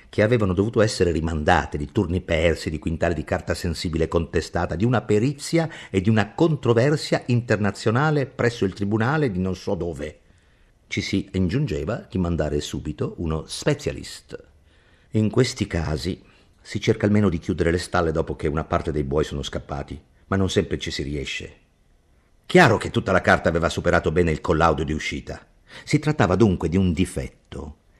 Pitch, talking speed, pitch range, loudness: 90 Hz, 170 wpm, 80-110 Hz, -23 LUFS